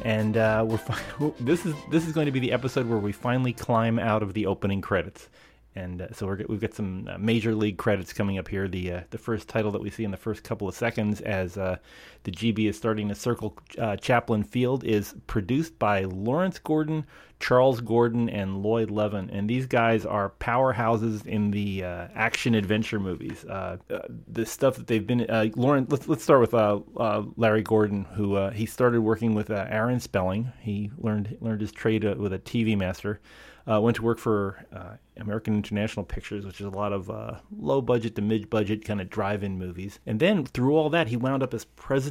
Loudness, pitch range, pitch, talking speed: -27 LUFS, 100-120 Hz, 110 Hz, 215 wpm